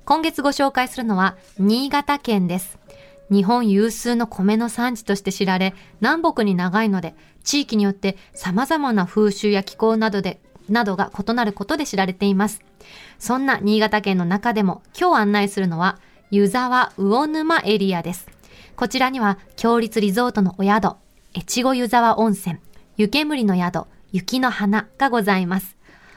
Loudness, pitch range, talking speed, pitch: -20 LUFS, 195-245 Hz, 295 characters per minute, 210 Hz